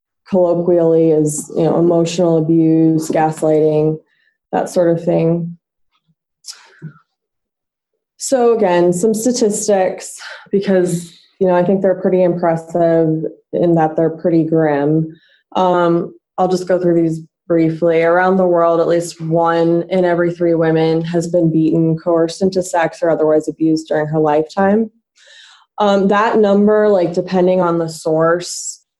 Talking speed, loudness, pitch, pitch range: 135 wpm, -15 LUFS, 170 Hz, 160-185 Hz